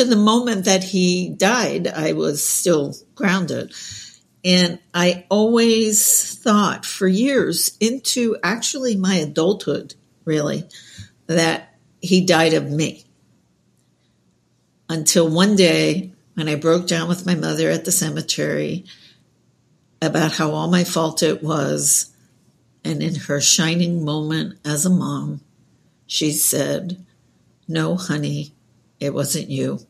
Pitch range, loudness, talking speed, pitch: 150-190 Hz, -18 LUFS, 120 wpm, 165 Hz